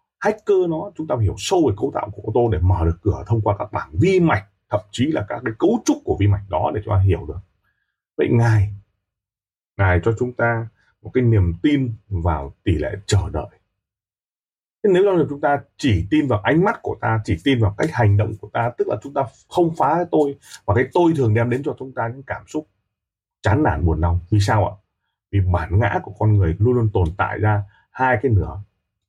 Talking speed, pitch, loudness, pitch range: 235 wpm, 105 Hz, -20 LUFS, 100-125 Hz